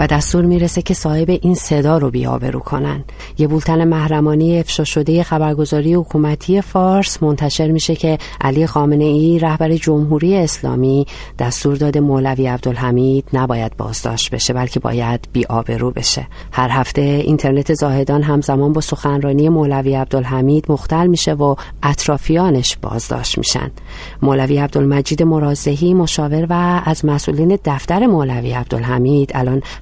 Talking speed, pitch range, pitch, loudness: 125 wpm, 135-160 Hz, 145 Hz, -15 LUFS